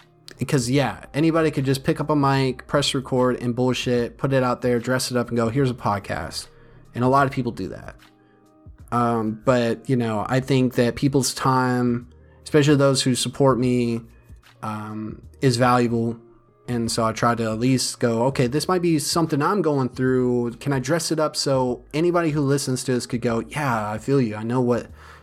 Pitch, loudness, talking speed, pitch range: 125 Hz, -22 LUFS, 200 wpm, 115-140 Hz